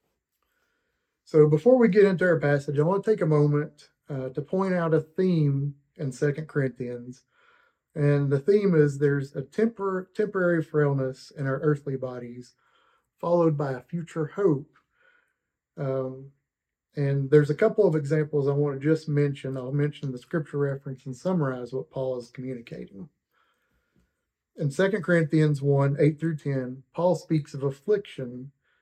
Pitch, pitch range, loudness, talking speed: 150 Hz, 135-170 Hz, -25 LUFS, 155 wpm